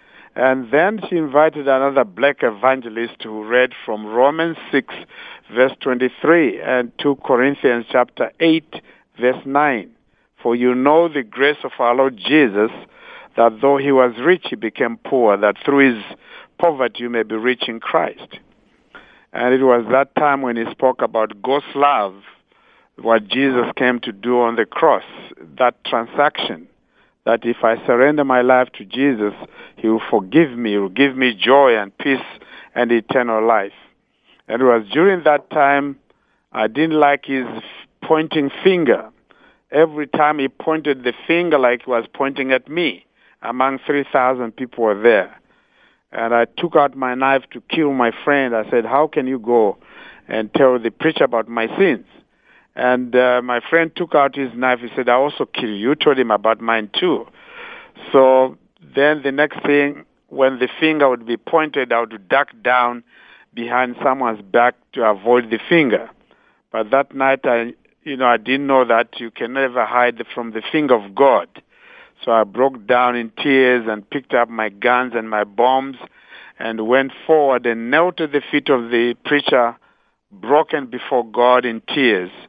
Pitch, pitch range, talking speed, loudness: 130 Hz, 120-140 Hz, 170 wpm, -17 LUFS